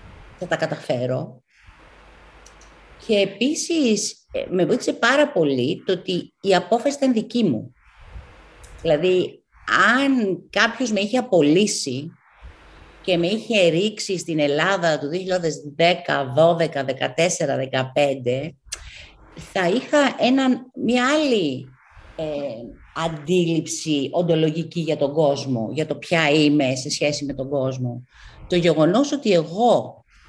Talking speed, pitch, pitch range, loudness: 115 wpm, 165 Hz, 140-210 Hz, -21 LUFS